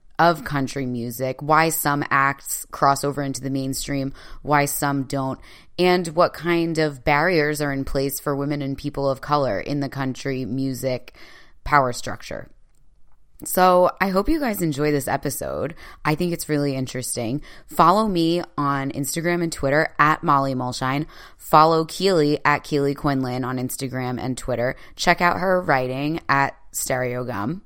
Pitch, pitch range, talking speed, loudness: 145 Hz, 135-155 Hz, 155 wpm, -22 LUFS